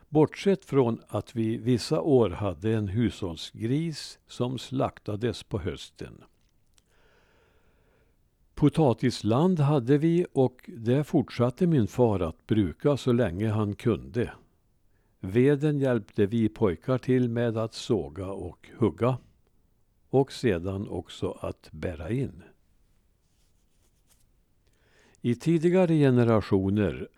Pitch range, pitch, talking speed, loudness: 100-135 Hz, 115 Hz, 100 wpm, -27 LUFS